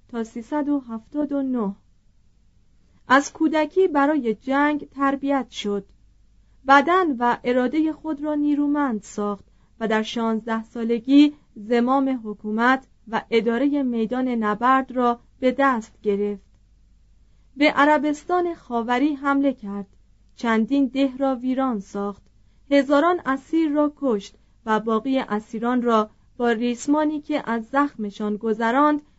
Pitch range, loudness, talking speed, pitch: 220-285 Hz, -22 LUFS, 110 wpm, 250 Hz